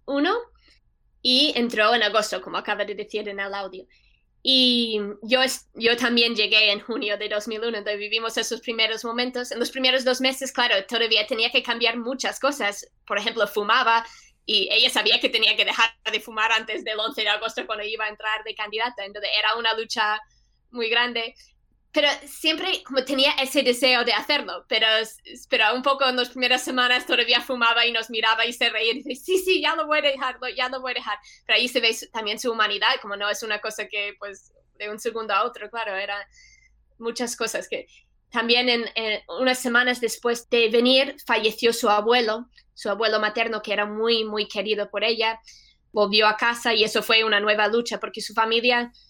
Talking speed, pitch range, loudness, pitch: 200 wpm, 215-250 Hz, -22 LUFS, 230 Hz